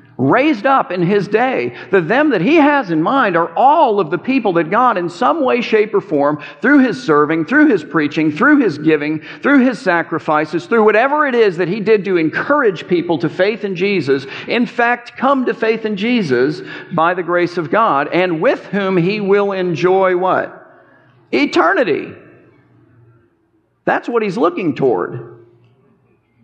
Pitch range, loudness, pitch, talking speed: 160-240 Hz, -14 LUFS, 190 Hz, 175 wpm